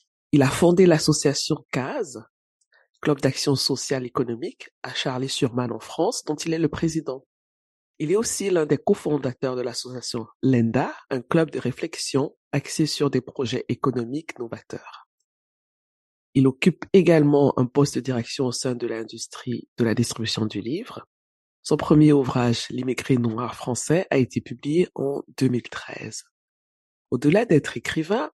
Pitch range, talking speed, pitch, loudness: 120-150 Hz, 145 wpm, 130 Hz, -23 LUFS